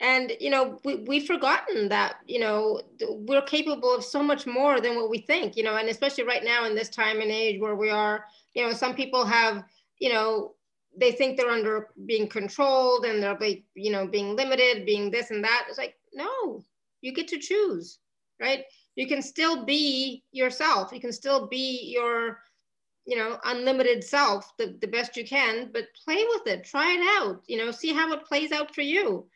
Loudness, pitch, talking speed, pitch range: -26 LUFS, 255 Hz, 205 wpm, 225-290 Hz